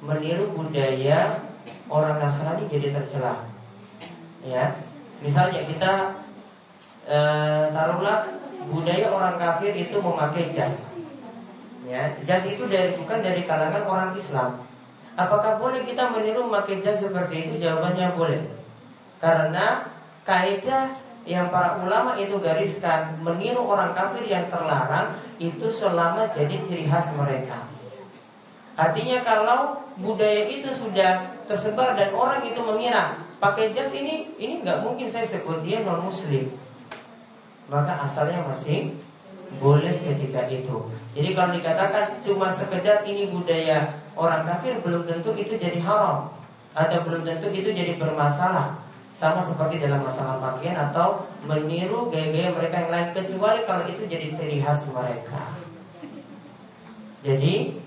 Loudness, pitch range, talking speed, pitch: -24 LUFS, 150-205 Hz, 125 wpm, 175 Hz